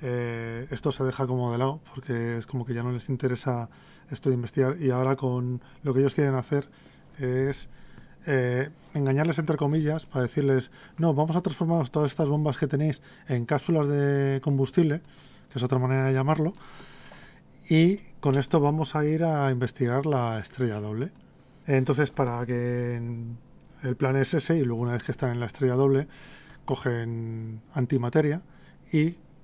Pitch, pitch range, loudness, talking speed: 135 Hz, 125-150 Hz, -27 LUFS, 175 wpm